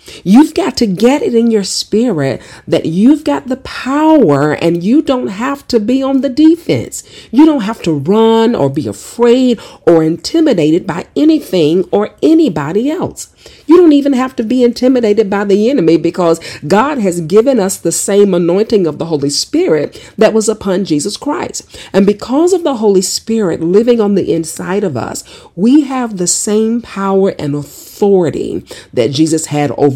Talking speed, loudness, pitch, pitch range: 175 wpm, -11 LUFS, 215 Hz, 170-260 Hz